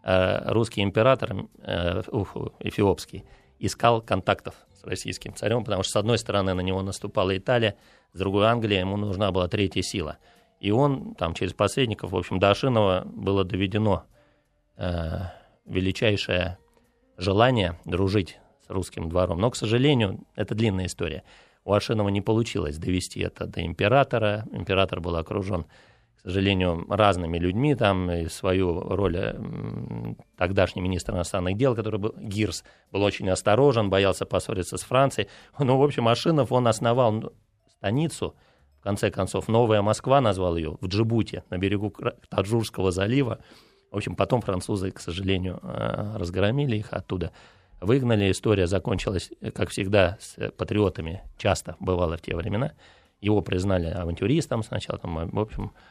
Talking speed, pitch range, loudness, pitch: 140 wpm, 90-110 Hz, -25 LUFS, 100 Hz